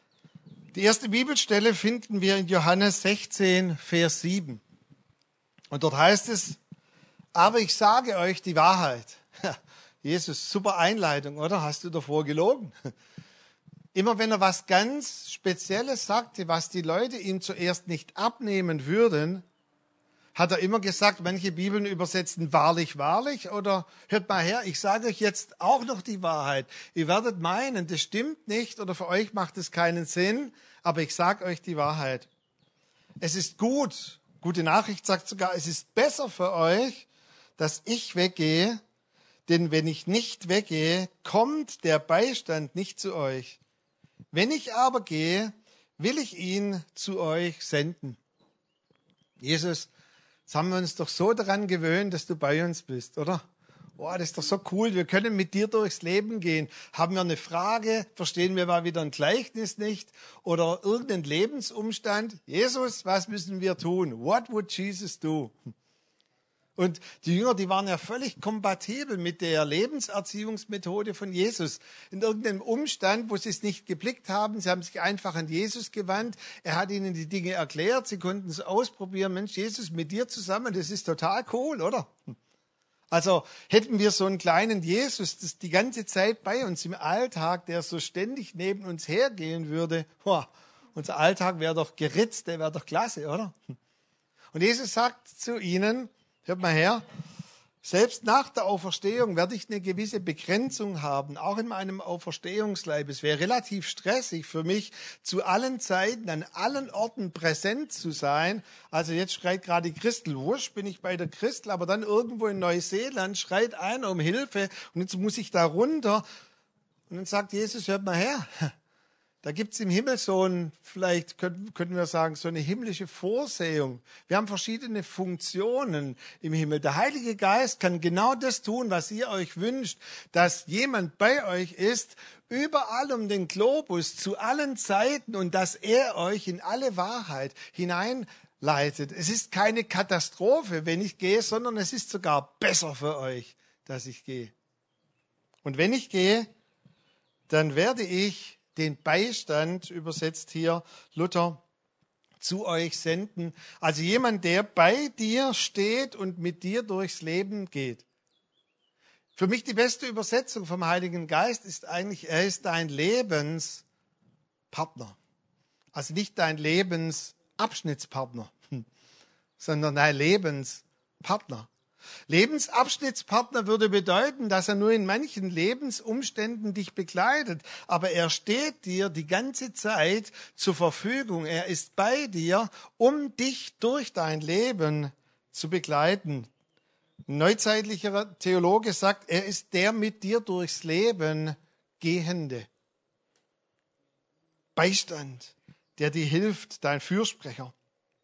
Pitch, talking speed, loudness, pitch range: 185 Hz, 145 wpm, -28 LUFS, 165-215 Hz